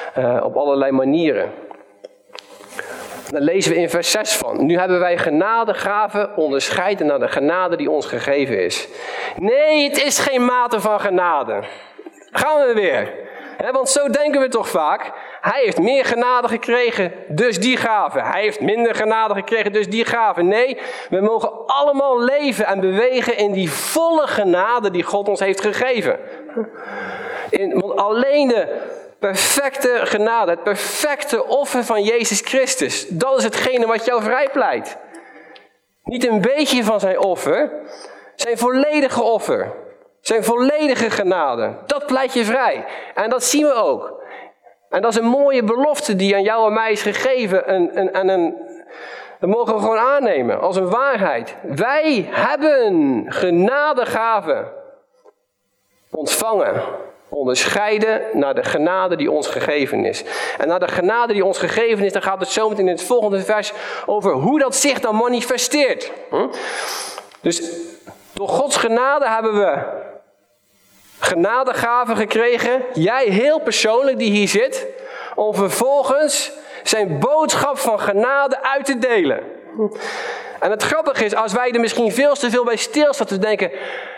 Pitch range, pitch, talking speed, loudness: 210-285 Hz, 240 Hz, 150 wpm, -17 LUFS